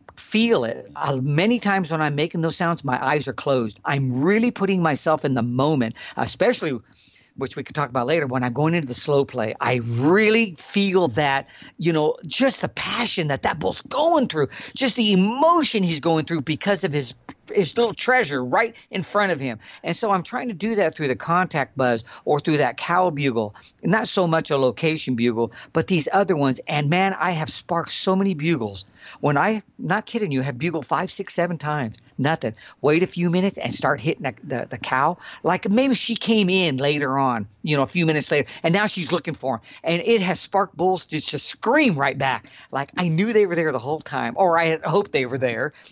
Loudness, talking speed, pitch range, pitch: -22 LUFS, 220 wpm, 135-195 Hz, 160 Hz